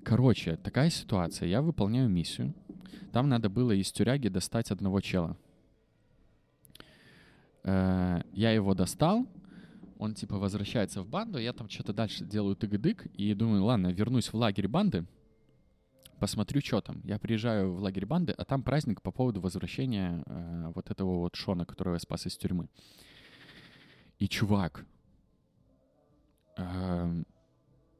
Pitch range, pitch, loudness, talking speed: 95-115 Hz, 100 Hz, -31 LUFS, 130 wpm